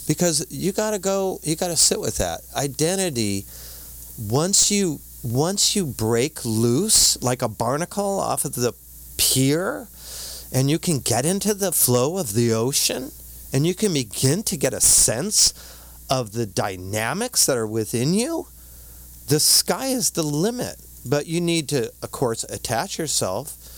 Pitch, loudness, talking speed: 130 Hz, -20 LUFS, 160 wpm